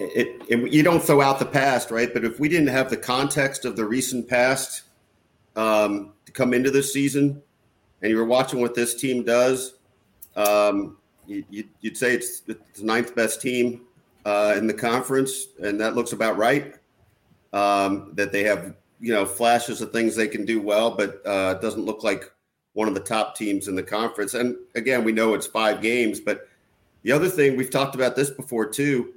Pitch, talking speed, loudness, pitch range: 120 Hz, 200 wpm, -23 LUFS, 105-130 Hz